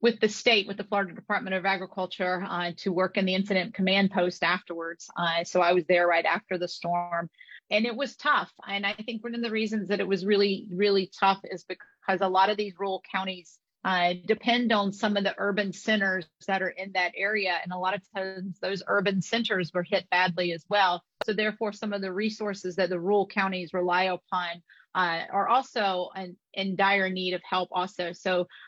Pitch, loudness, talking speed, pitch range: 190 Hz, -27 LUFS, 210 wpm, 180-205 Hz